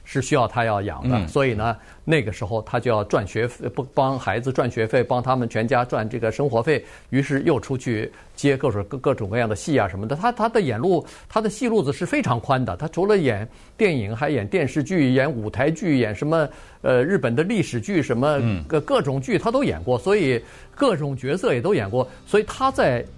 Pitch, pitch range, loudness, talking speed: 135 Hz, 115-150 Hz, -22 LUFS, 315 characters per minute